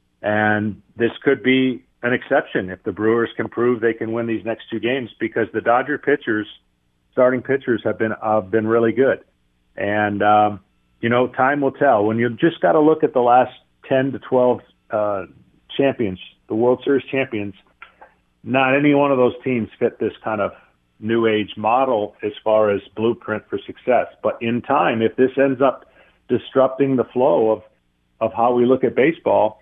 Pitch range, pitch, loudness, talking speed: 105-130 Hz, 115 Hz, -19 LUFS, 185 wpm